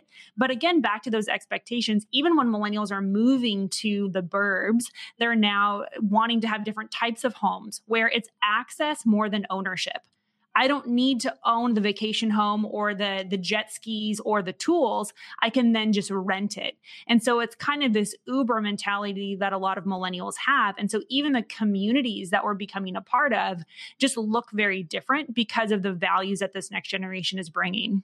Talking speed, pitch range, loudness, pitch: 195 wpm, 200-235 Hz, -25 LUFS, 215 Hz